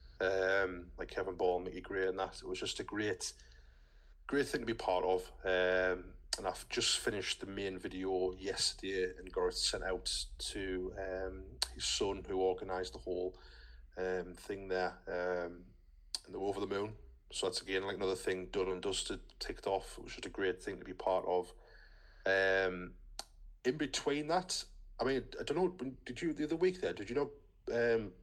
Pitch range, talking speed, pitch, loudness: 90-95 Hz, 190 wpm, 95 Hz, -37 LUFS